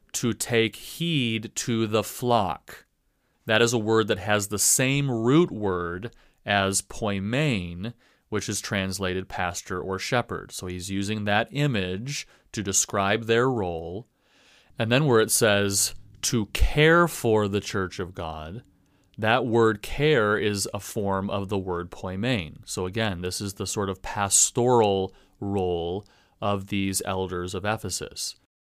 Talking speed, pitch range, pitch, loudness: 145 wpm, 95-115 Hz, 105 Hz, -25 LUFS